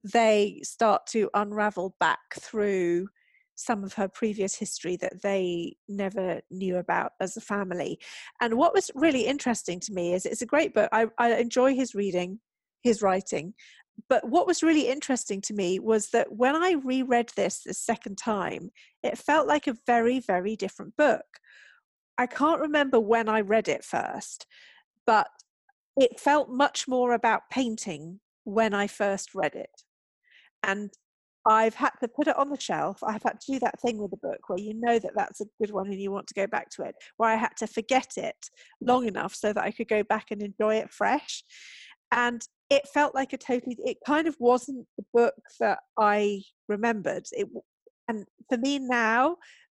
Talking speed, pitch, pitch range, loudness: 185 wpm, 225 Hz, 205-260 Hz, -27 LUFS